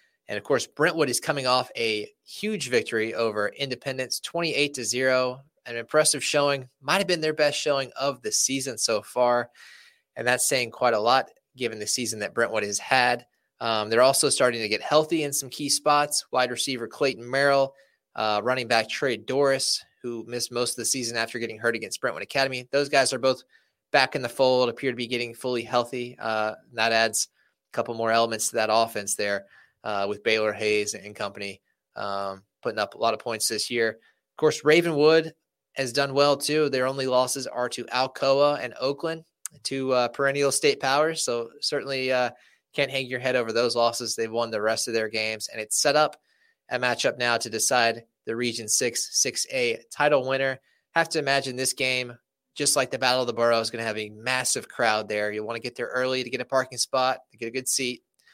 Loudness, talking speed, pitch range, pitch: -25 LUFS, 205 wpm, 115-140 Hz, 125 Hz